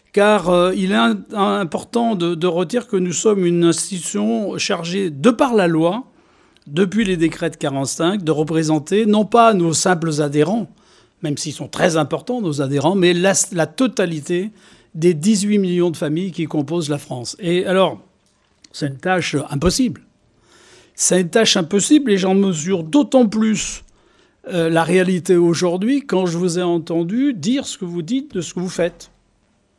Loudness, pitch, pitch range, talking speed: -18 LUFS, 180 Hz, 165-210 Hz, 165 wpm